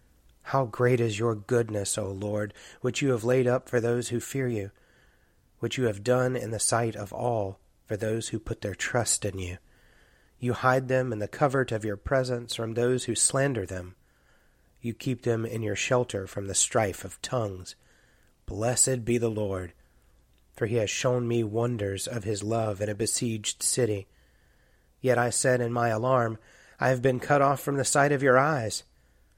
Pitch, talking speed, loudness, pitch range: 115 Hz, 190 wpm, -27 LUFS, 105-125 Hz